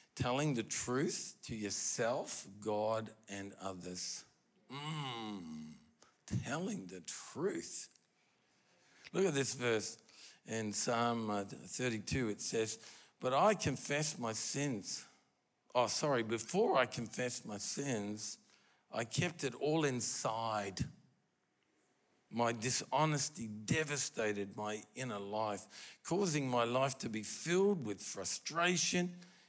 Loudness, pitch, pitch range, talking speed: -38 LUFS, 120 Hz, 105-145 Hz, 105 wpm